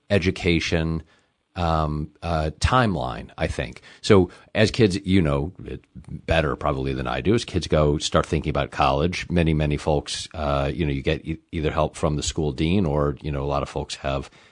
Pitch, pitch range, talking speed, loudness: 80 Hz, 75-90 Hz, 190 wpm, -23 LUFS